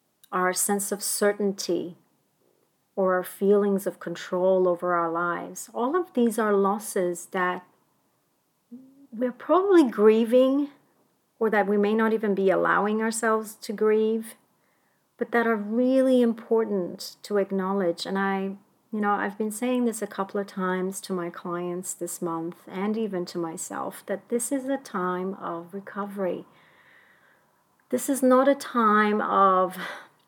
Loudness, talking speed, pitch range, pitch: -25 LUFS, 145 wpm, 185-230 Hz, 205 Hz